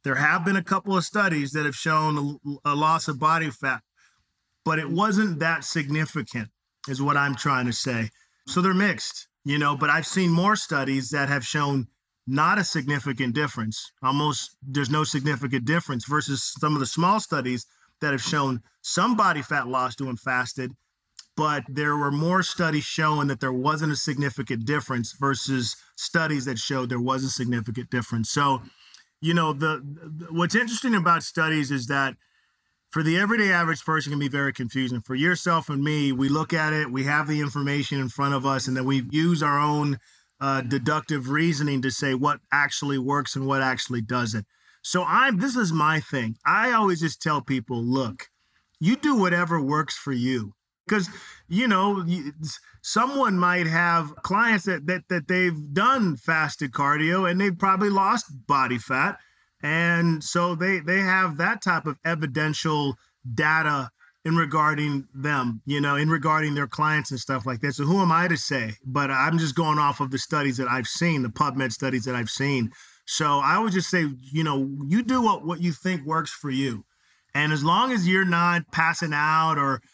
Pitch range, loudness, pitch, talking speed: 135-165 Hz, -24 LUFS, 150 Hz, 185 wpm